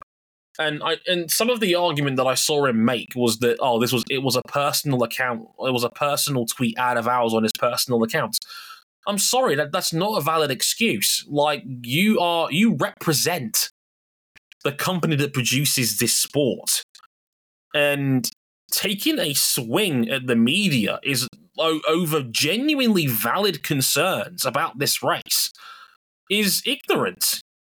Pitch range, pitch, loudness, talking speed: 125-175 Hz, 145 Hz, -21 LUFS, 150 wpm